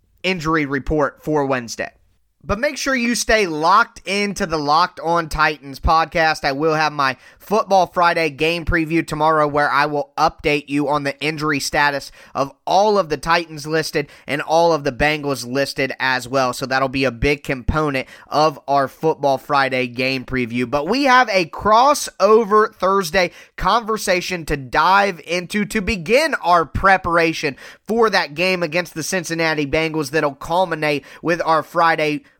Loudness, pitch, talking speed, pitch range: -18 LUFS, 155 Hz, 160 wpm, 145-185 Hz